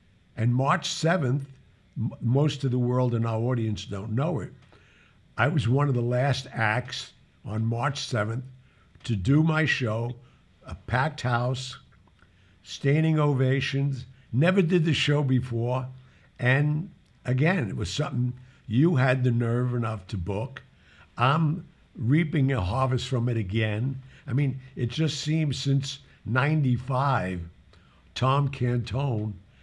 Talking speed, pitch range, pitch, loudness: 135 wpm, 115-140 Hz, 130 Hz, -26 LUFS